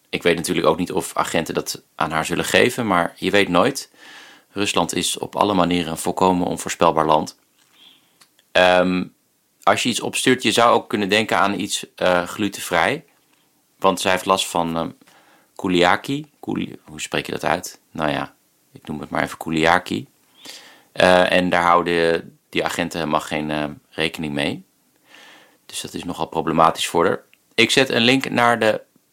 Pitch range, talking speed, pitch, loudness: 80-95 Hz, 175 wpm, 90 Hz, -19 LUFS